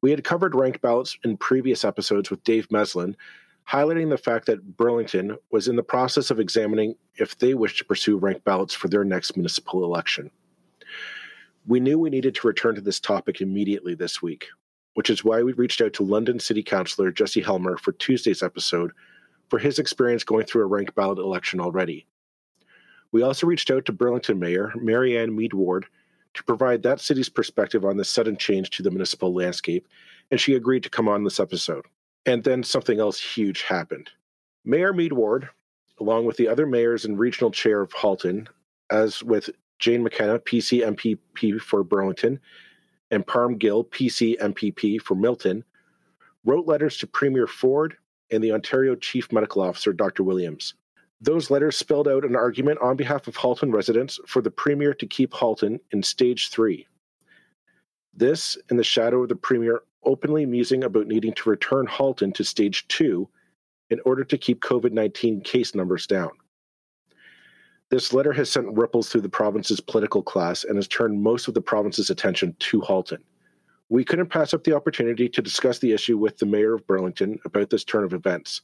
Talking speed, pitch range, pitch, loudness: 180 wpm, 105-130 Hz, 115 Hz, -23 LUFS